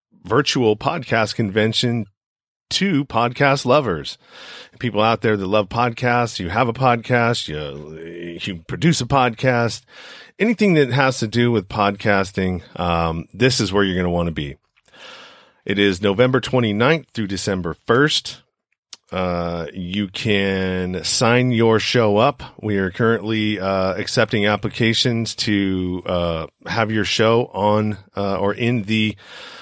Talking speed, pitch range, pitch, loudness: 140 wpm, 95-120 Hz, 110 Hz, -19 LUFS